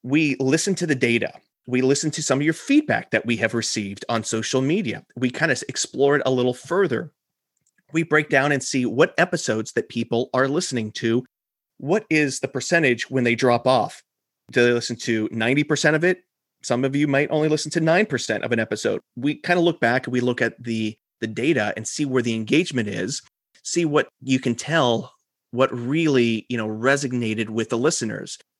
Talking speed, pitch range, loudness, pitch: 205 wpm, 120-155 Hz, -22 LUFS, 130 Hz